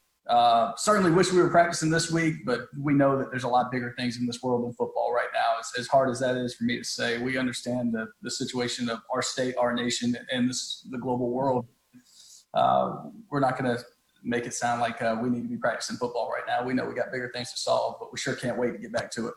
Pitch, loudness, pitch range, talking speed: 125 Hz, -27 LUFS, 120-130 Hz, 265 wpm